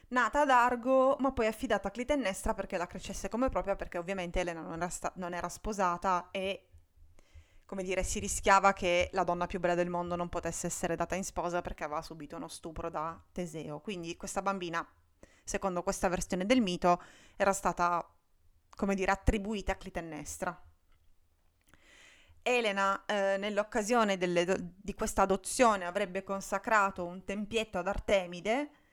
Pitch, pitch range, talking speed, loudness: 190 Hz, 175-200 Hz, 160 wpm, -32 LUFS